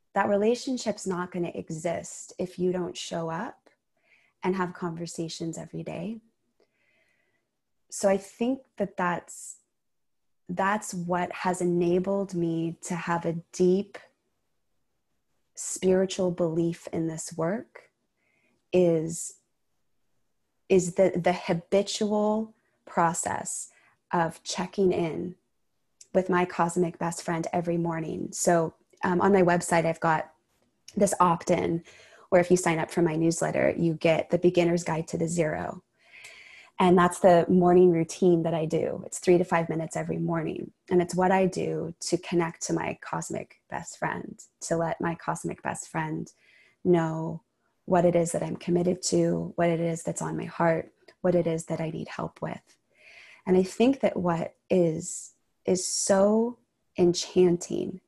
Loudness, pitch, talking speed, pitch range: -27 LUFS, 175 Hz, 145 wpm, 165-185 Hz